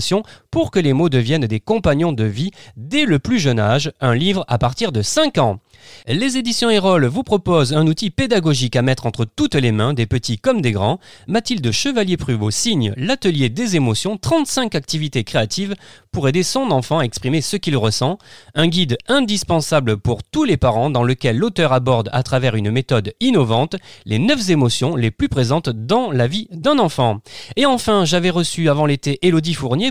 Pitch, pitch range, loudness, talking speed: 145 Hz, 120-185 Hz, -17 LUFS, 185 wpm